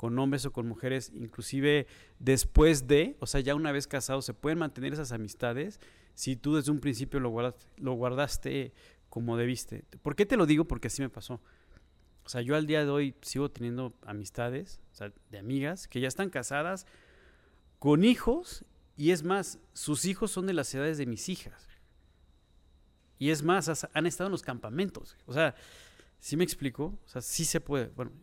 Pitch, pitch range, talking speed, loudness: 135 Hz, 120-155 Hz, 190 wpm, -31 LUFS